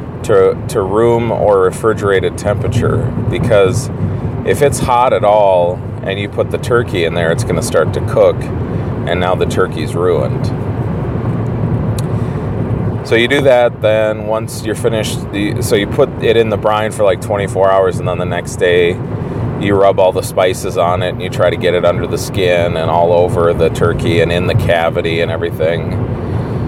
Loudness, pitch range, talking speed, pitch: -14 LUFS, 95-120 Hz, 185 wpm, 110 Hz